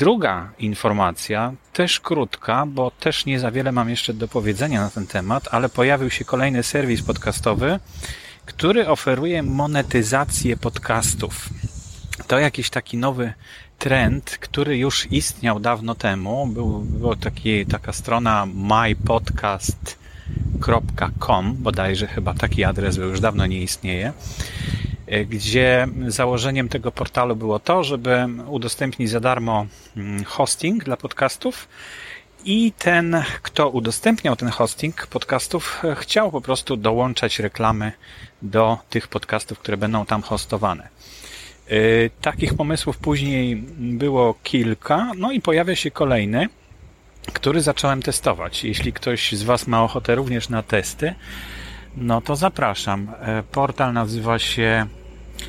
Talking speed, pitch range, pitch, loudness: 120 wpm, 105-135 Hz, 115 Hz, -21 LUFS